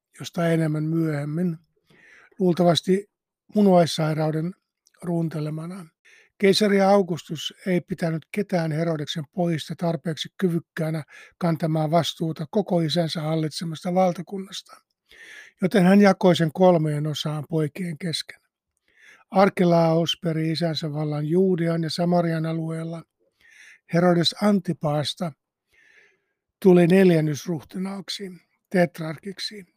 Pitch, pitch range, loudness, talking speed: 170 Hz, 160-185 Hz, -23 LUFS, 85 wpm